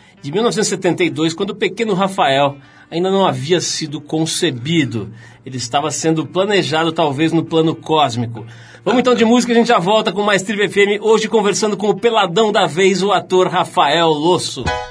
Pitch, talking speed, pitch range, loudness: 175 Hz, 170 wpm, 155-205 Hz, -15 LUFS